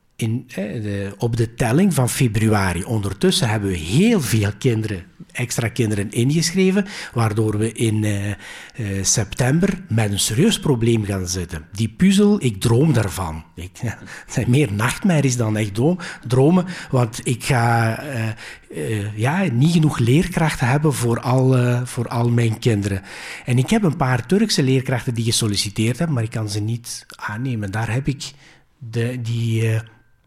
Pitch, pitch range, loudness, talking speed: 120 Hz, 110-140 Hz, -20 LUFS, 160 wpm